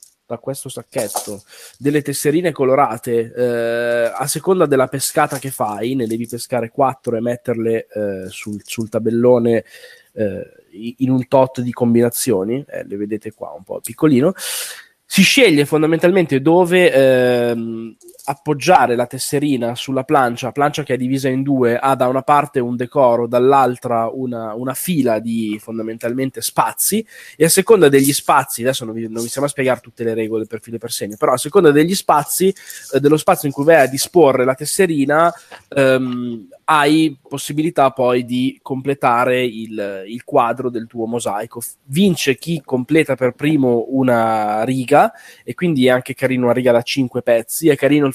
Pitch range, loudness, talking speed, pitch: 120-145 Hz, -16 LUFS, 165 wpm, 130 Hz